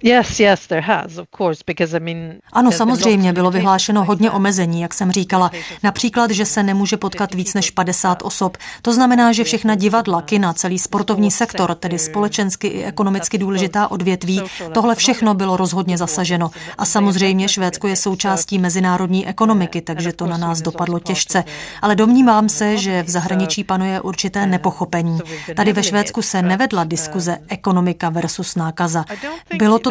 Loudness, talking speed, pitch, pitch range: -16 LUFS, 140 wpm, 190 Hz, 175-210 Hz